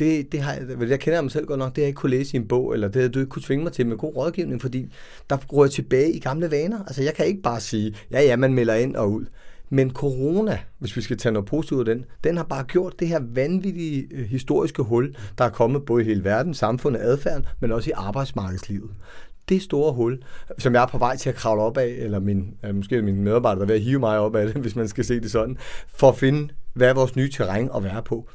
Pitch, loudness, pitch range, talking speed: 130 Hz, -23 LUFS, 115-145 Hz, 275 wpm